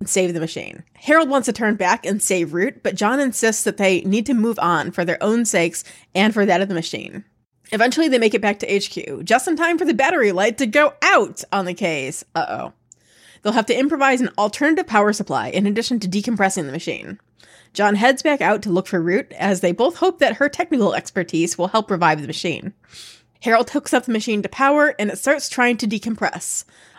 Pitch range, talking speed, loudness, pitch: 185-255 Hz, 225 wpm, -19 LUFS, 210 Hz